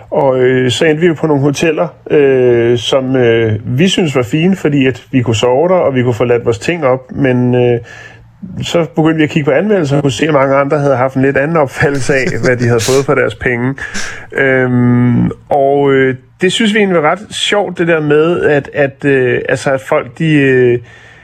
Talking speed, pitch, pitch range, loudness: 225 wpm, 135 Hz, 125-155 Hz, -11 LUFS